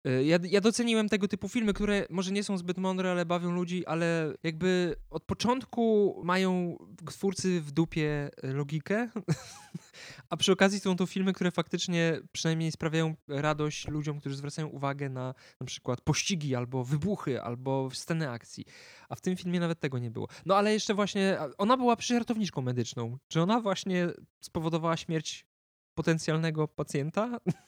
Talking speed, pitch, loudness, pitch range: 155 wpm, 170 Hz, -30 LUFS, 145-195 Hz